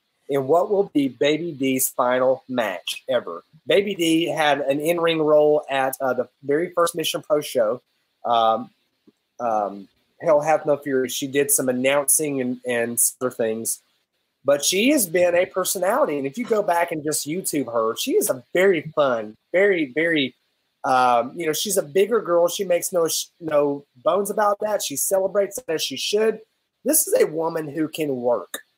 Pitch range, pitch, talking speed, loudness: 135-185 Hz, 155 Hz, 180 wpm, -21 LUFS